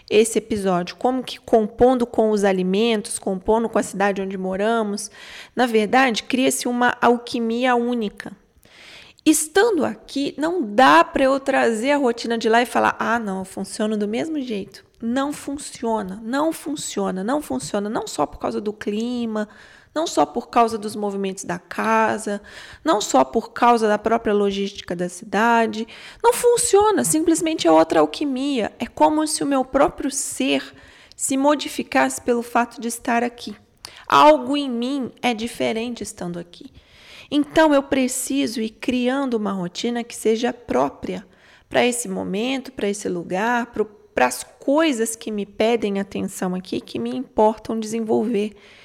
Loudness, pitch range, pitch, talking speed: -21 LUFS, 210-270 Hz, 230 Hz, 150 wpm